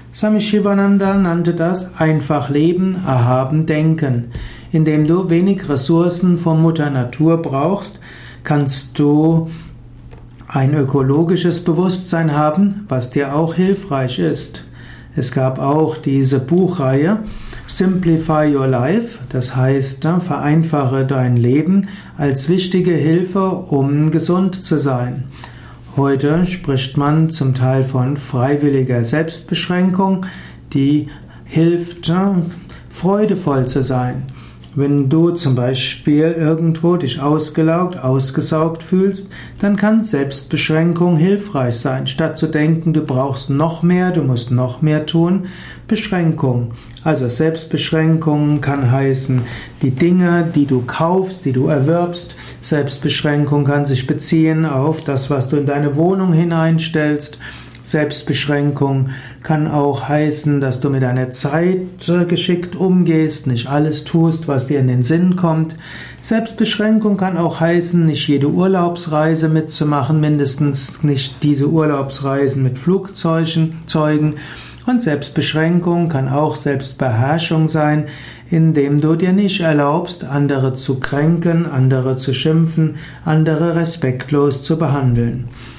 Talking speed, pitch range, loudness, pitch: 115 wpm, 135-170 Hz, -16 LUFS, 155 Hz